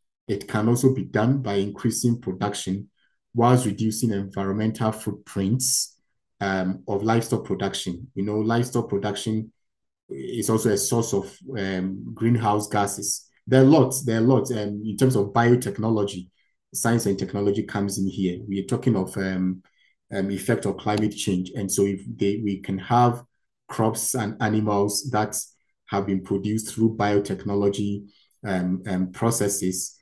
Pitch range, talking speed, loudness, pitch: 100-115 Hz, 150 wpm, -24 LUFS, 105 Hz